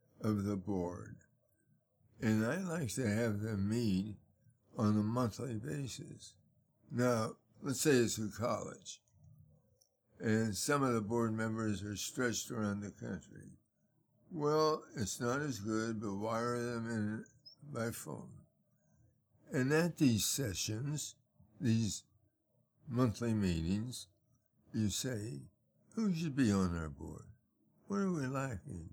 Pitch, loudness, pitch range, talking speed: 115 Hz, -37 LUFS, 105-130 Hz, 125 wpm